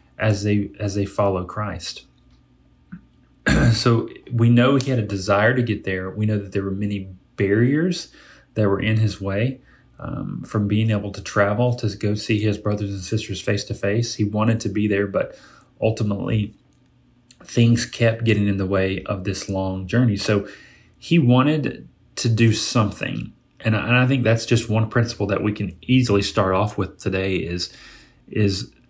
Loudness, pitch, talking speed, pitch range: -21 LUFS, 105 Hz, 175 wpm, 100-120 Hz